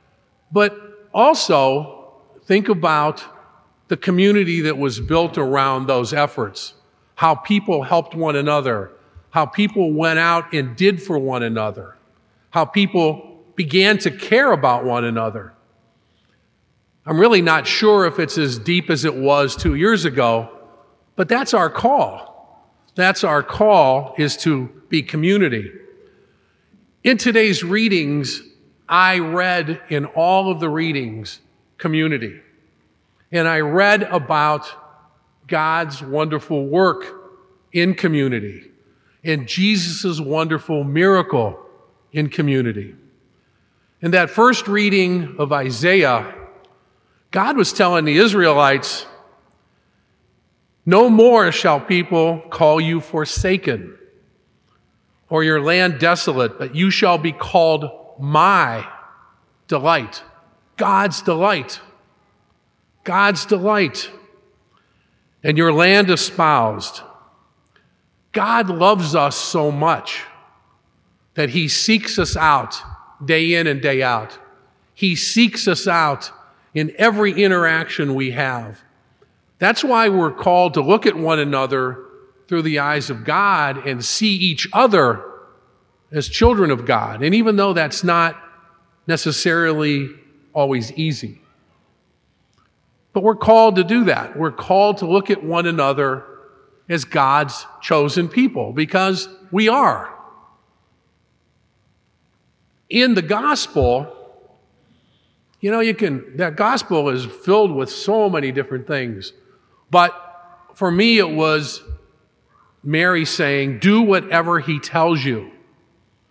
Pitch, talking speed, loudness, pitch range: 165 Hz, 115 wpm, -17 LUFS, 145-190 Hz